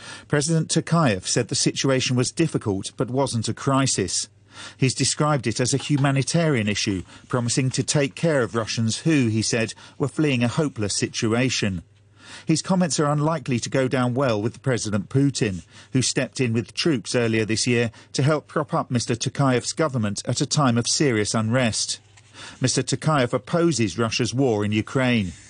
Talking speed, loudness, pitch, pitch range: 165 wpm, -22 LUFS, 125 Hz, 110-145 Hz